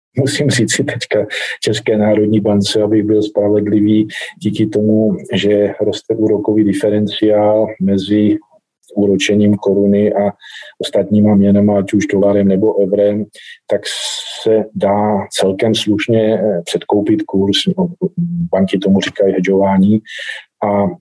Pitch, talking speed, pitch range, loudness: 105 Hz, 110 wpm, 100-110 Hz, -14 LUFS